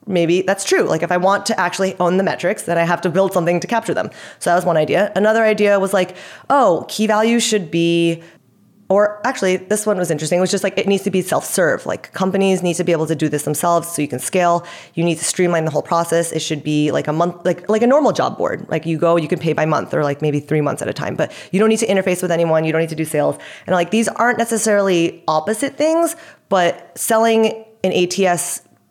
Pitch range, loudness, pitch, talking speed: 170-205 Hz, -17 LUFS, 180 Hz, 255 wpm